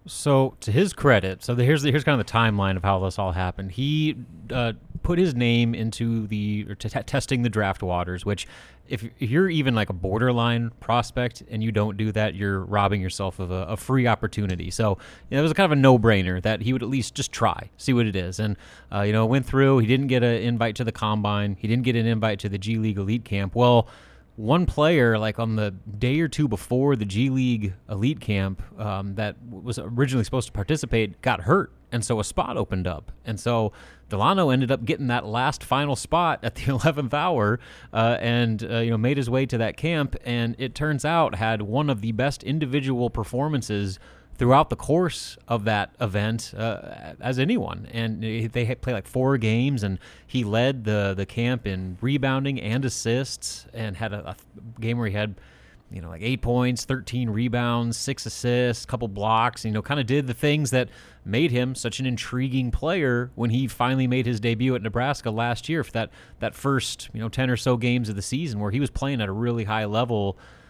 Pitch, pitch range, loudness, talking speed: 115 Hz, 105-130 Hz, -24 LUFS, 220 wpm